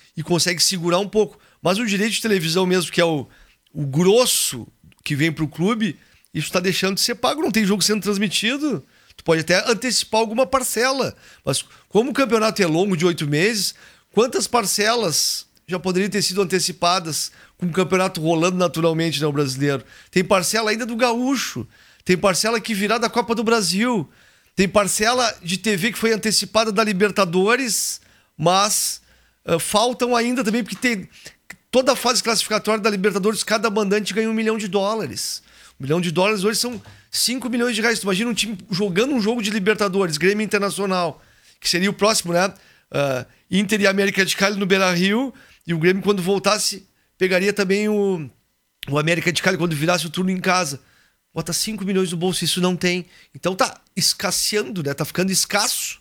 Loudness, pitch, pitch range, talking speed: -20 LUFS, 195 Hz, 175-220 Hz, 185 wpm